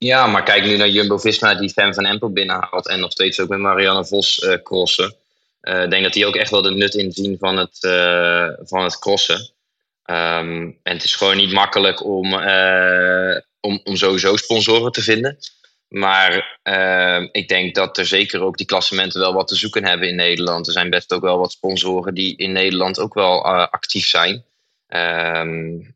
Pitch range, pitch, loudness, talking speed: 90-100 Hz, 95 Hz, -16 LUFS, 195 wpm